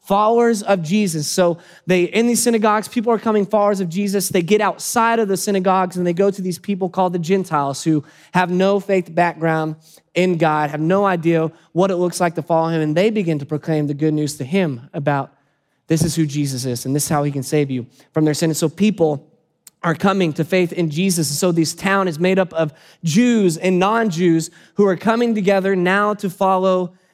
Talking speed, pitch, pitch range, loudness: 220 wpm, 180 Hz, 160-195 Hz, -18 LUFS